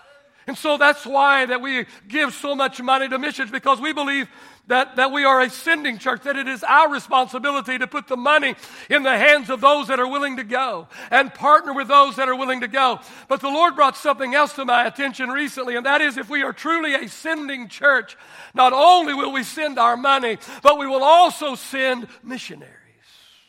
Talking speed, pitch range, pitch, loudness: 210 wpm, 255-285 Hz, 270 Hz, -18 LUFS